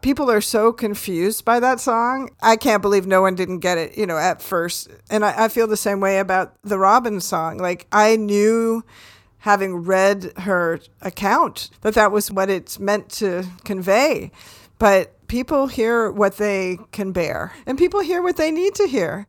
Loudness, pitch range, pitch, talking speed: -19 LUFS, 190-230 Hz, 205 Hz, 185 wpm